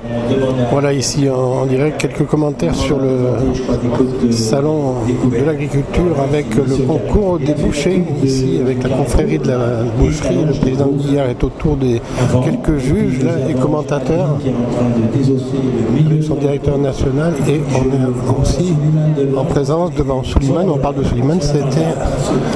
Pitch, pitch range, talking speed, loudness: 135 Hz, 130-150 Hz, 130 wpm, -15 LUFS